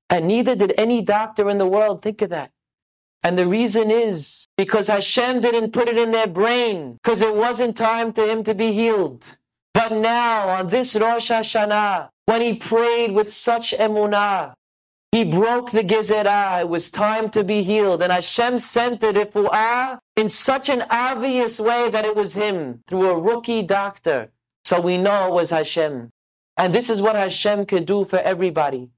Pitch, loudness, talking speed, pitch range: 215 Hz, -19 LUFS, 180 wpm, 195-230 Hz